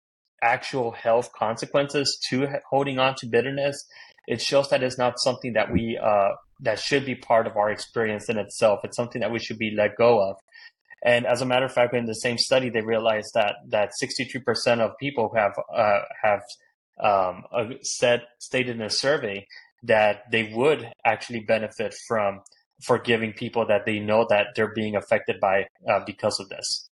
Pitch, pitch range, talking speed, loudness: 120 Hz, 110-130 Hz, 180 wpm, -24 LUFS